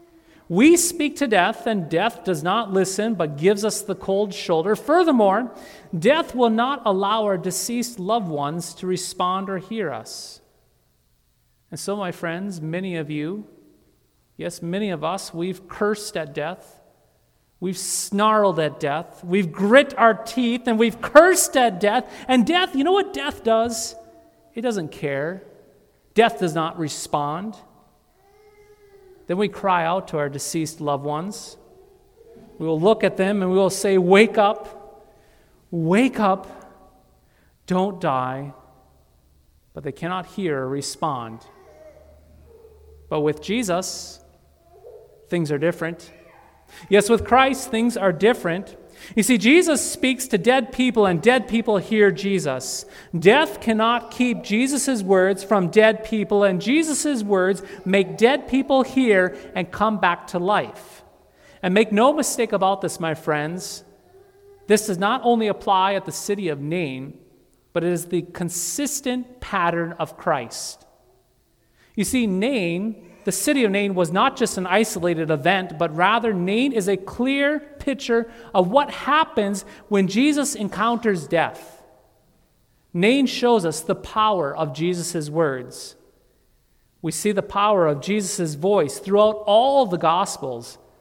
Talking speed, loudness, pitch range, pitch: 145 wpm, -21 LUFS, 170-235 Hz, 200 Hz